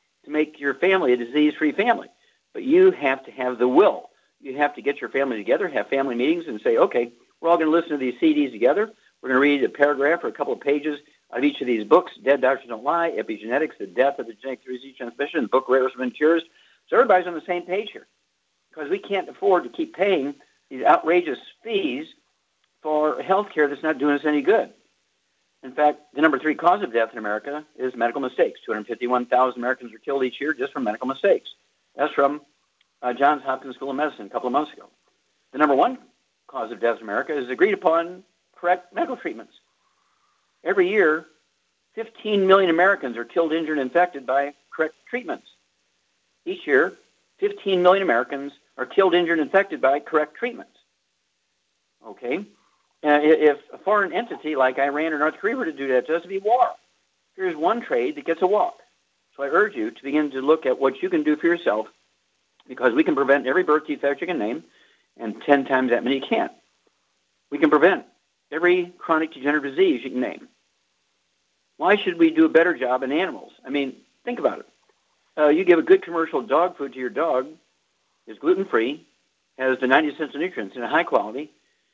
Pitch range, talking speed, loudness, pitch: 135-195 Hz, 200 wpm, -22 LUFS, 155 Hz